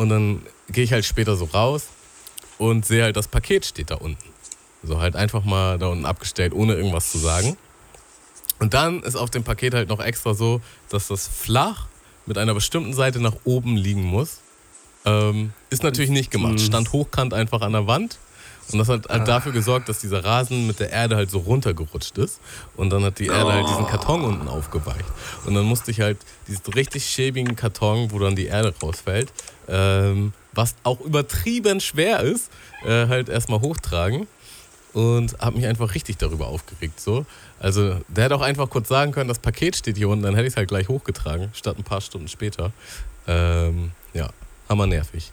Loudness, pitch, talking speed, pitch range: -22 LUFS, 110 Hz, 195 wpm, 95-120 Hz